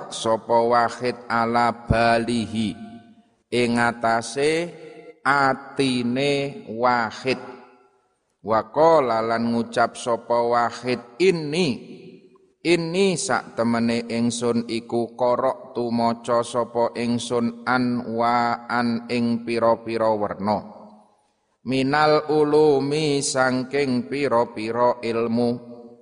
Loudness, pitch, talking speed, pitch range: -22 LUFS, 120 Hz, 75 wpm, 115-135 Hz